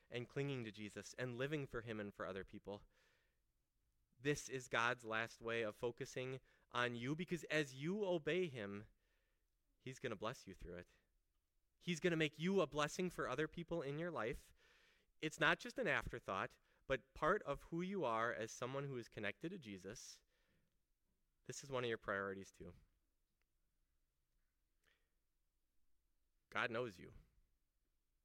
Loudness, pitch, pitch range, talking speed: -44 LUFS, 120 Hz, 100-155 Hz, 155 wpm